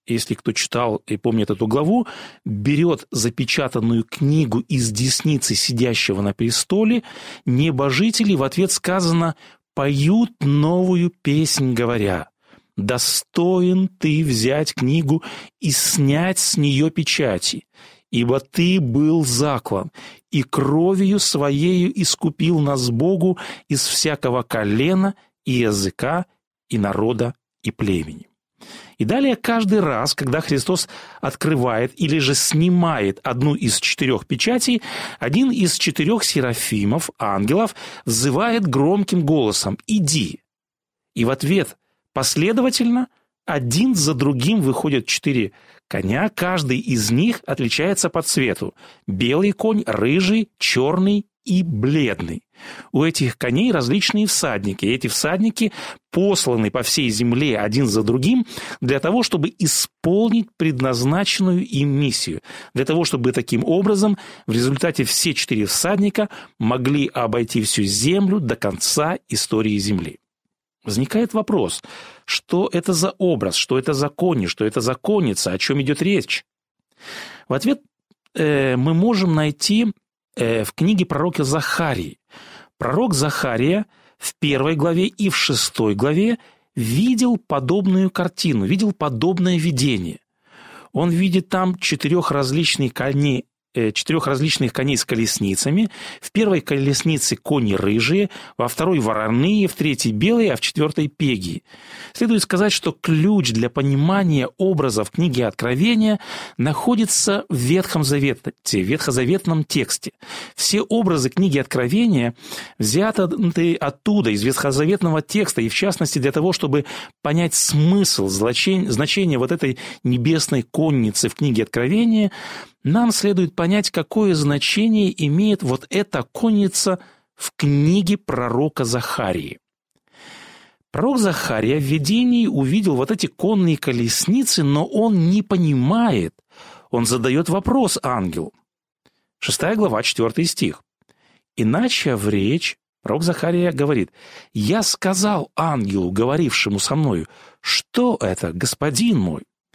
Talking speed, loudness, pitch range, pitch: 120 wpm, -19 LUFS, 130-190 Hz, 155 Hz